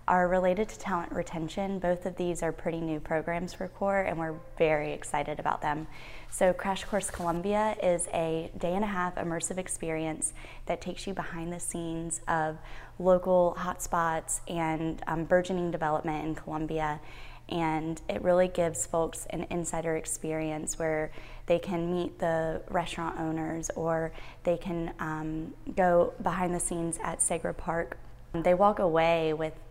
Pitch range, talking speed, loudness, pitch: 160-180 Hz, 155 wpm, -30 LUFS, 165 Hz